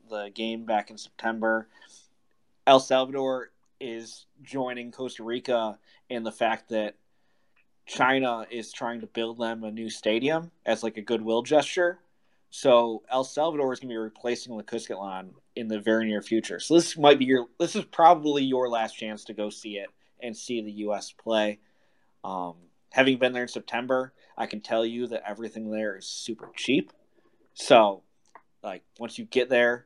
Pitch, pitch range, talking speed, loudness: 115 Hz, 110-130 Hz, 175 wpm, -26 LUFS